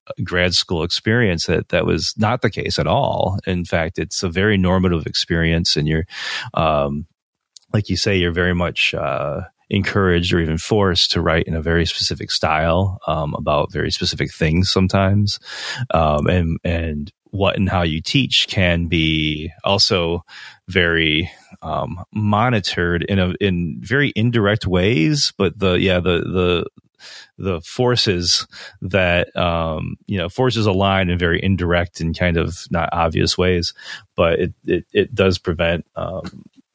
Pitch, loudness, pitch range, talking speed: 90 Hz, -18 LUFS, 85-100 Hz, 155 wpm